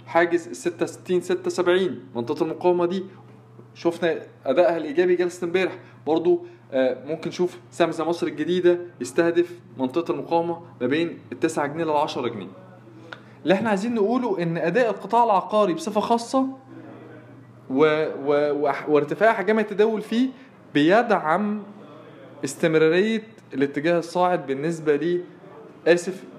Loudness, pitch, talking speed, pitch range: -23 LUFS, 170 Hz, 120 wpm, 150-185 Hz